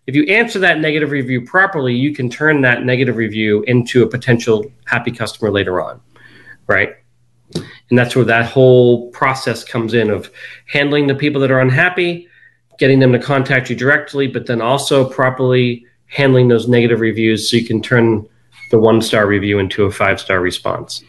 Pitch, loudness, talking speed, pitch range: 125 Hz, -14 LUFS, 180 wpm, 115-135 Hz